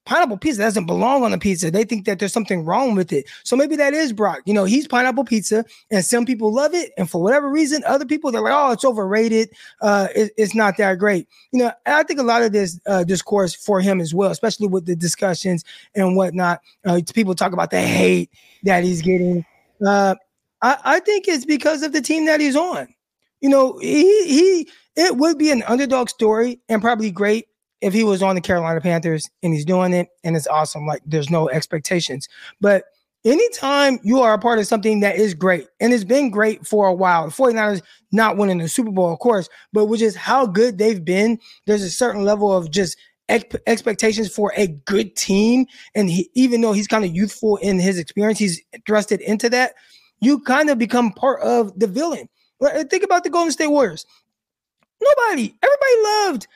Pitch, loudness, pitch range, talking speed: 215 Hz, -18 LUFS, 190-260 Hz, 210 wpm